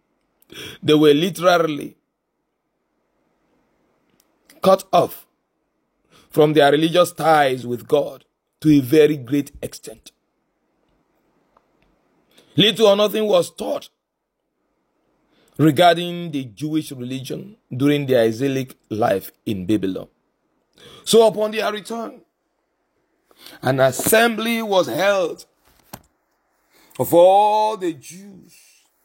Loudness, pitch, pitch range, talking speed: -18 LUFS, 165 Hz, 140-200 Hz, 90 wpm